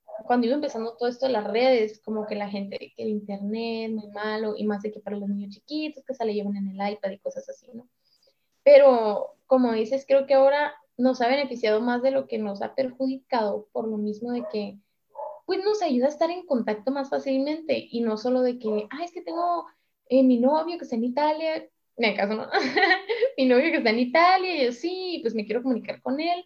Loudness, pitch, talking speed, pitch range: -25 LUFS, 250 Hz, 225 wpm, 215-285 Hz